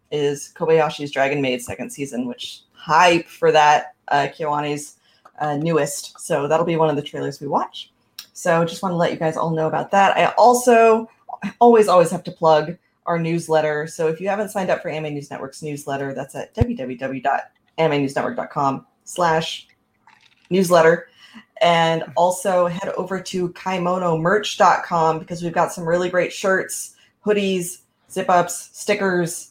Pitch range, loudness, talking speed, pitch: 145-180 Hz, -19 LUFS, 155 wpm, 165 Hz